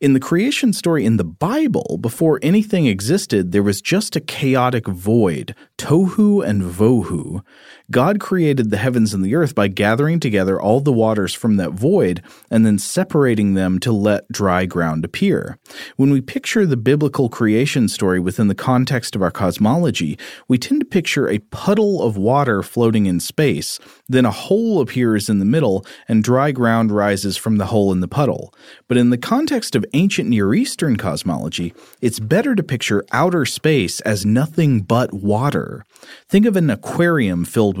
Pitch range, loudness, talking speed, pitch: 105-160 Hz, -17 LUFS, 175 wpm, 120 Hz